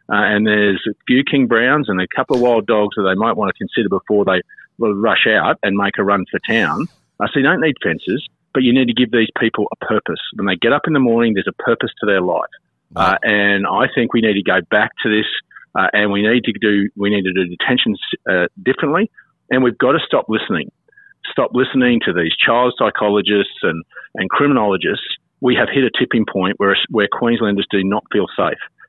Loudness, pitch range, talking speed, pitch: -16 LUFS, 100-125 Hz, 220 wpm, 110 Hz